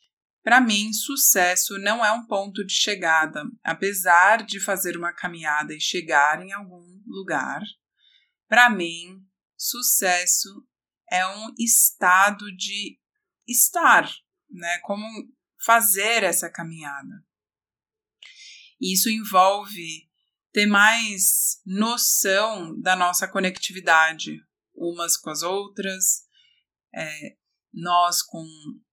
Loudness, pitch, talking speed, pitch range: -20 LUFS, 195 Hz, 100 wpm, 175-220 Hz